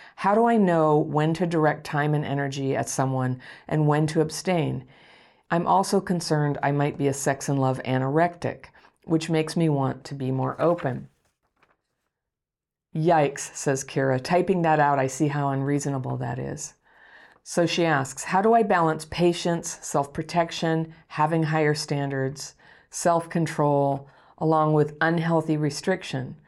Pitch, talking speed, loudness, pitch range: 155 Hz, 150 wpm, -24 LUFS, 140-165 Hz